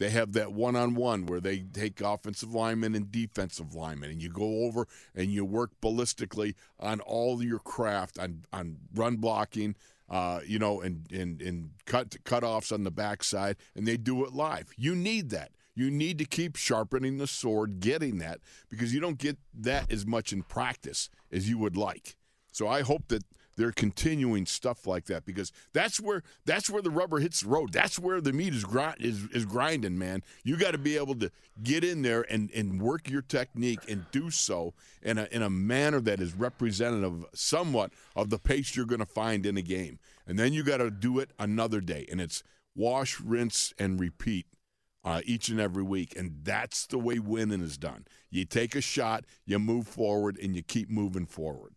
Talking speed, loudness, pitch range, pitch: 205 wpm, -31 LUFS, 95-125 Hz, 110 Hz